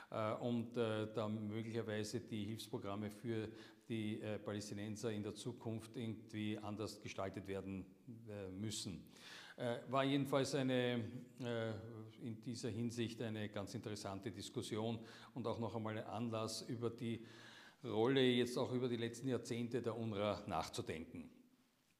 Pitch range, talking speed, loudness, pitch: 105-120 Hz, 135 wpm, -44 LUFS, 115 Hz